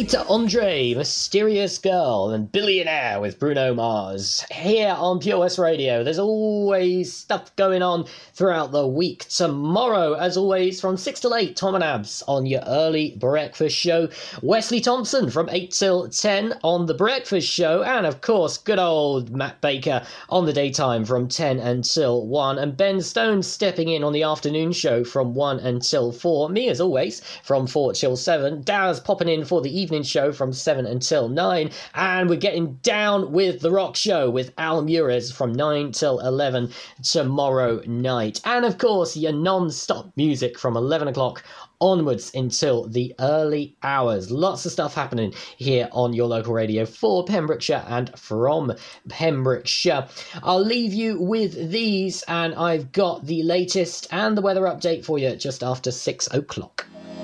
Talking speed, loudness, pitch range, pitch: 165 wpm, -22 LUFS, 130-185 Hz, 160 Hz